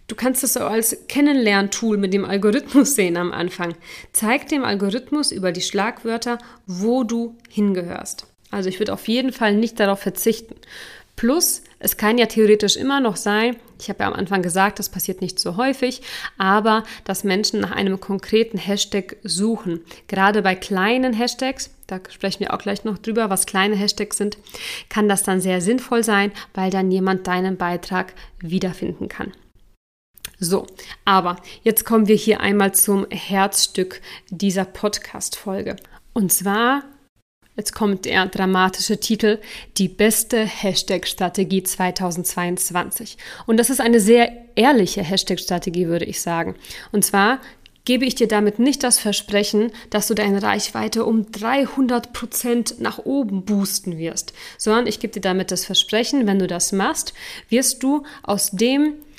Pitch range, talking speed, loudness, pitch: 190-235 Hz, 155 wpm, -20 LUFS, 205 Hz